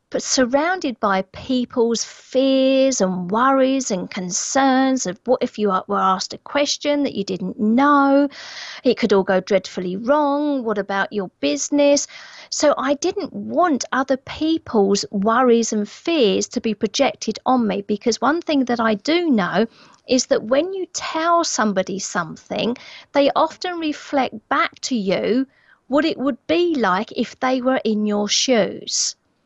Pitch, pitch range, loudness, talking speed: 255 Hz, 210-285 Hz, -19 LUFS, 155 wpm